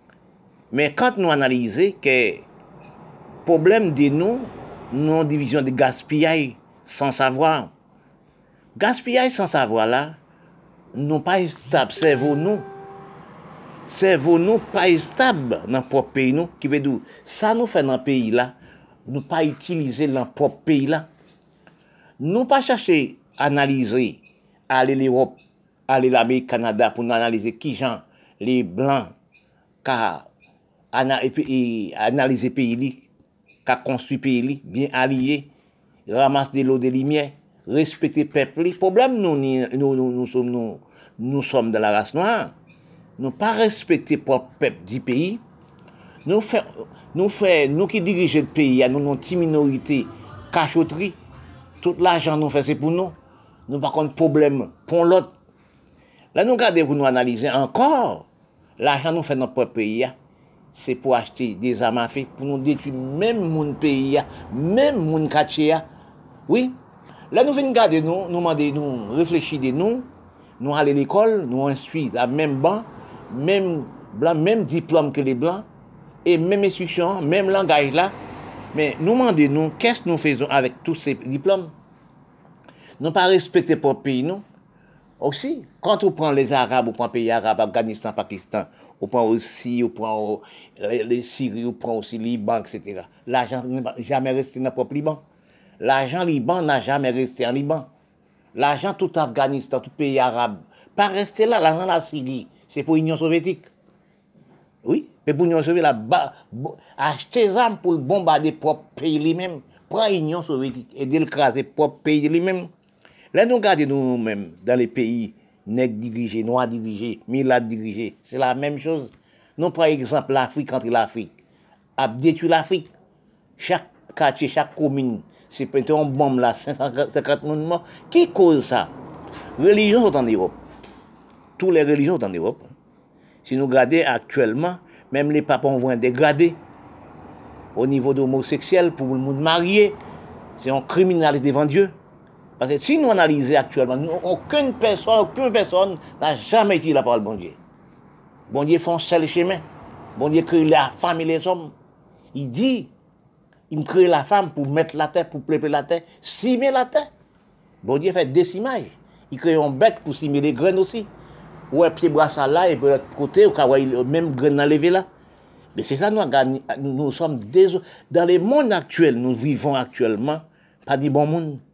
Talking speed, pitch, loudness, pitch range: 160 wpm, 150 Hz, -20 LUFS, 130-175 Hz